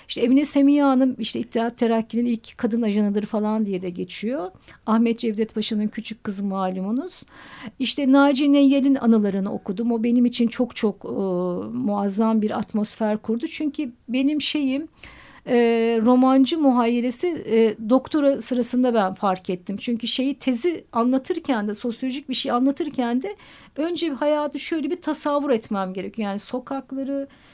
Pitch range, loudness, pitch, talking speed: 220-275 Hz, -22 LUFS, 240 Hz, 145 wpm